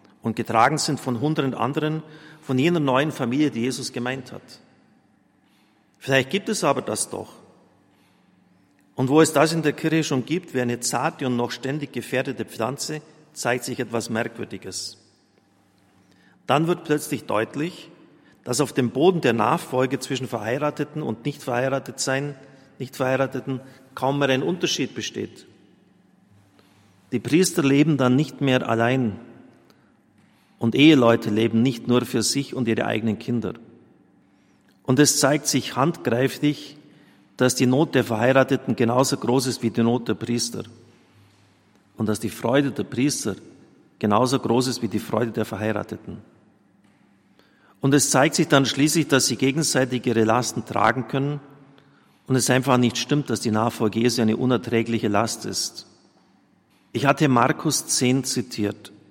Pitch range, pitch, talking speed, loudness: 115-140 Hz, 125 Hz, 145 wpm, -22 LUFS